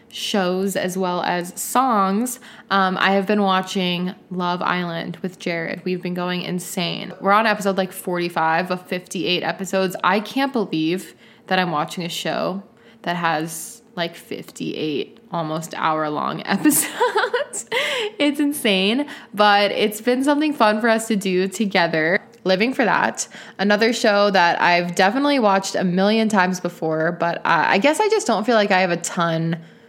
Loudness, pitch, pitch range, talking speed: -20 LUFS, 190 Hz, 175-225 Hz, 160 wpm